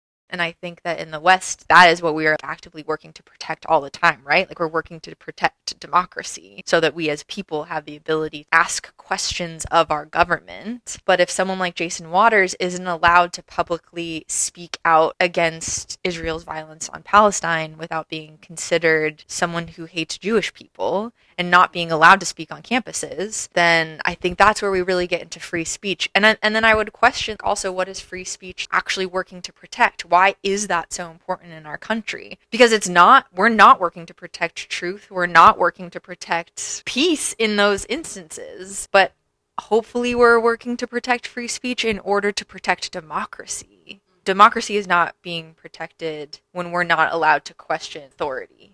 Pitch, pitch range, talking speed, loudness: 175 Hz, 165-200 Hz, 185 wpm, -19 LUFS